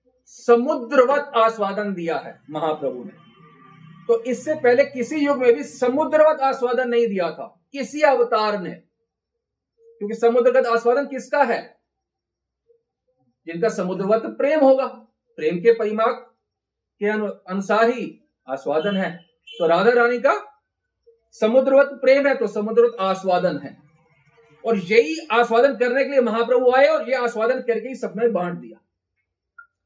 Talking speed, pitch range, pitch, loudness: 130 wpm, 195-265 Hz, 235 Hz, -20 LUFS